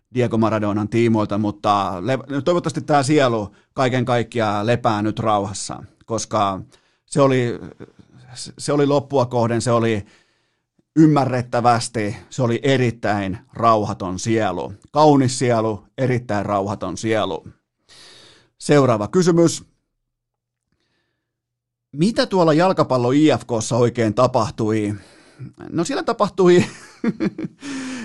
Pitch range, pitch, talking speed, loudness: 110-140 Hz, 120 Hz, 90 wpm, -19 LUFS